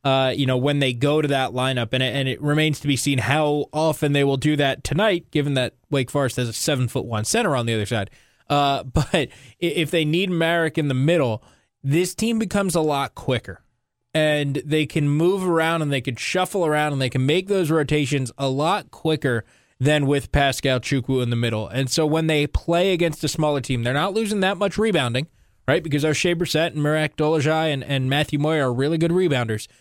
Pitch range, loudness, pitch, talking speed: 130-160 Hz, -21 LUFS, 145 Hz, 220 wpm